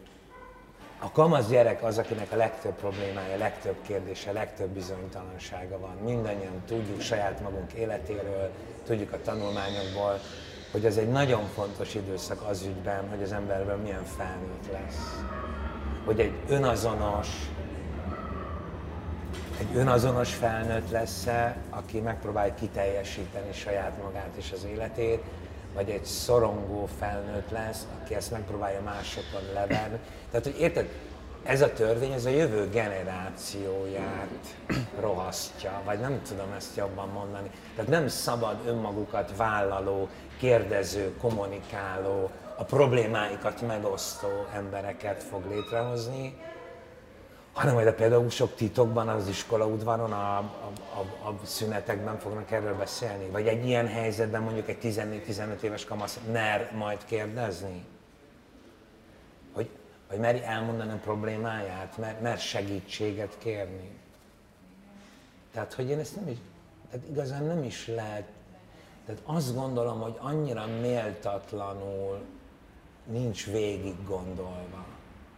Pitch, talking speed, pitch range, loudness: 105 Hz, 120 wpm, 95-115 Hz, -31 LUFS